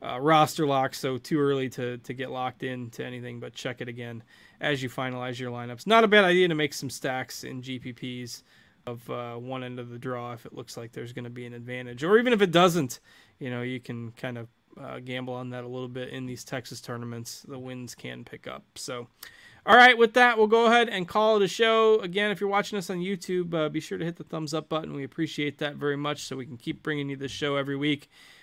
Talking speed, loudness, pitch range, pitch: 255 wpm, -26 LUFS, 125-160 Hz, 130 Hz